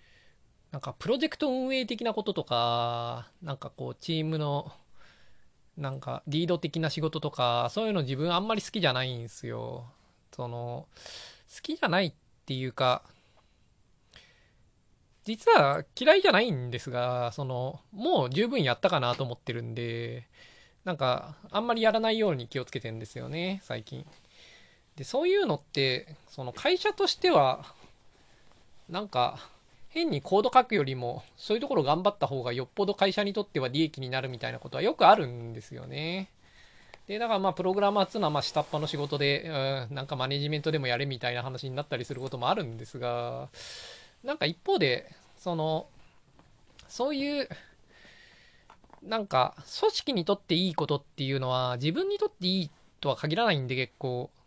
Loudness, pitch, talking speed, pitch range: -29 LUFS, 150 Hz, 345 characters per minute, 125-200 Hz